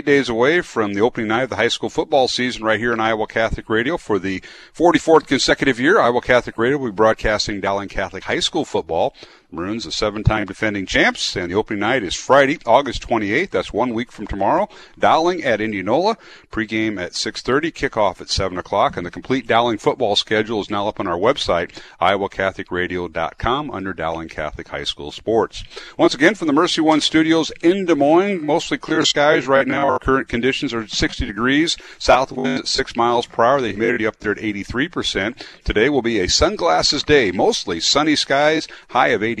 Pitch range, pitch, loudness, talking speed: 105-140 Hz, 115 Hz, -18 LUFS, 200 wpm